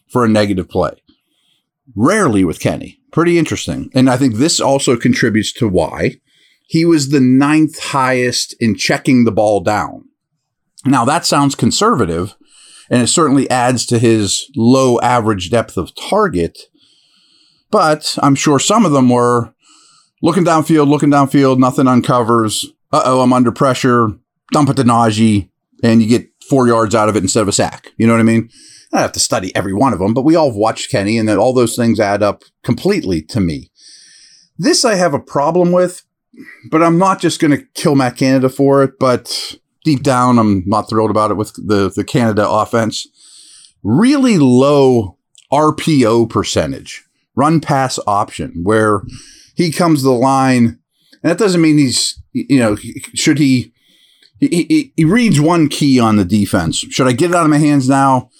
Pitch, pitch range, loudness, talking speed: 130 Hz, 115-150 Hz, -13 LUFS, 180 wpm